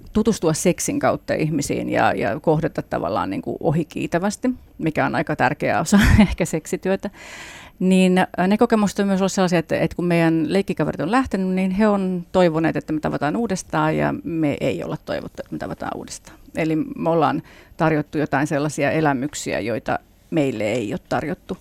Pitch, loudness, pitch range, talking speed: 180 Hz, -21 LUFS, 160-200 Hz, 165 wpm